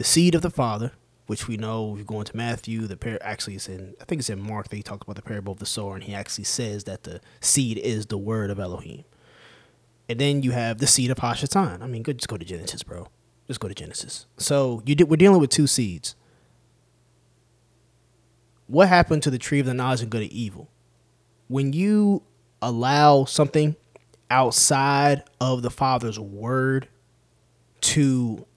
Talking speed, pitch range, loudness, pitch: 195 wpm, 110-135 Hz, -23 LUFS, 120 Hz